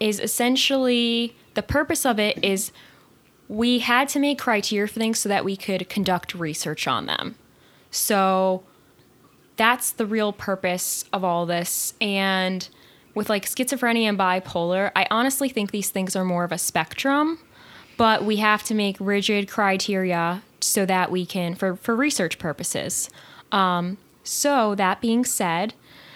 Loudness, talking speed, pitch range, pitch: -22 LUFS, 150 wpm, 185-230 Hz, 205 Hz